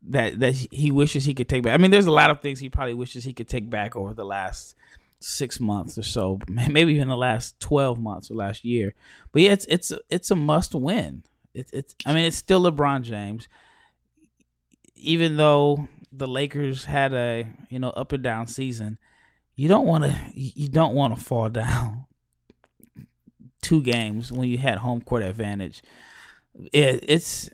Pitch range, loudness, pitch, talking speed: 115-145 Hz, -23 LUFS, 130 Hz, 185 wpm